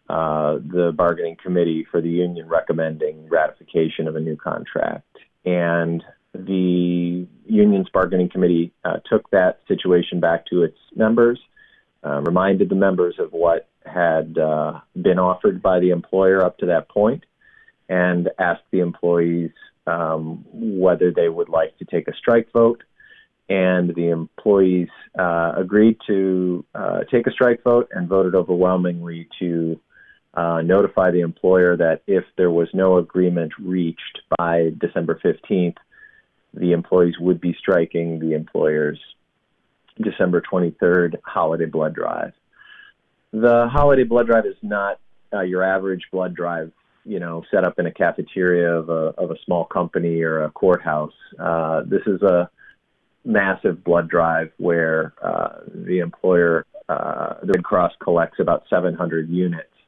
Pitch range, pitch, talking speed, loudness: 85-95 Hz, 90 Hz, 145 wpm, -20 LUFS